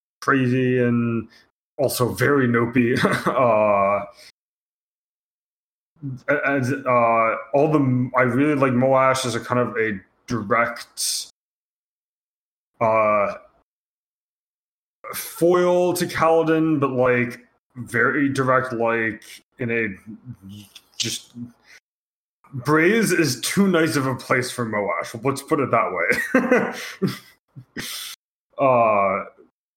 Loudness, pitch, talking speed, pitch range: -20 LUFS, 125 Hz, 95 wpm, 115-145 Hz